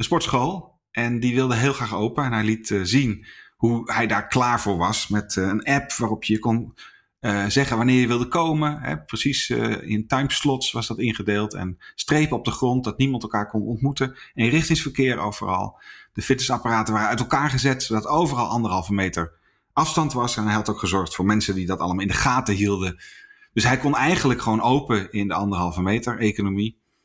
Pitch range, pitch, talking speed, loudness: 105-130 Hz, 115 Hz, 200 wpm, -22 LUFS